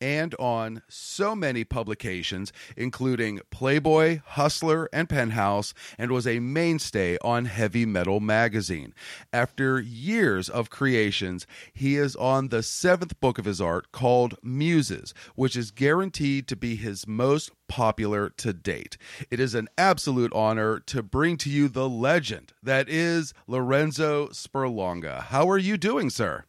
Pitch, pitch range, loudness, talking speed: 125 Hz, 110-145 Hz, -26 LUFS, 145 wpm